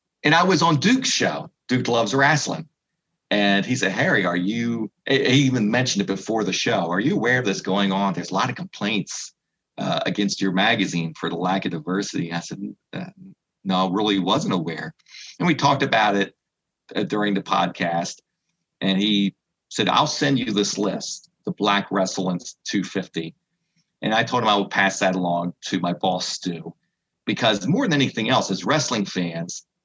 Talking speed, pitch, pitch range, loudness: 185 wpm, 100 Hz, 95-125 Hz, -22 LUFS